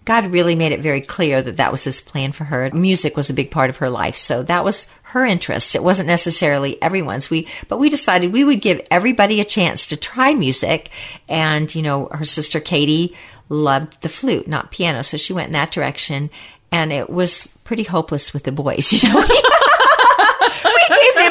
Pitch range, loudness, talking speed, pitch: 140-185 Hz, -15 LUFS, 205 wpm, 160 Hz